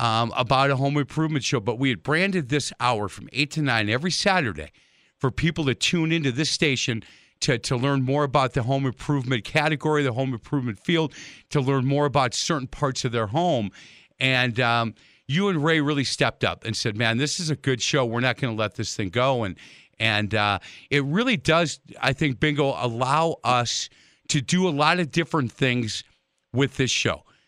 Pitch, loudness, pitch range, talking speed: 135 Hz, -23 LUFS, 120-150 Hz, 200 wpm